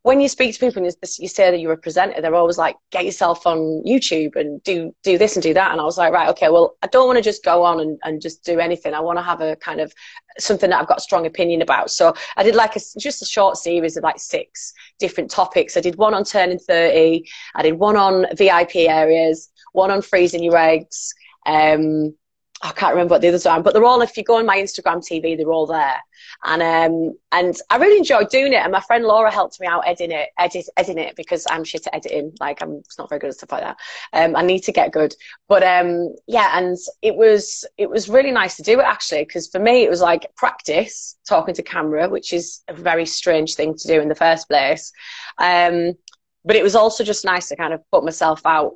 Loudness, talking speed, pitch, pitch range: -17 LUFS, 250 wpm, 175 Hz, 165-215 Hz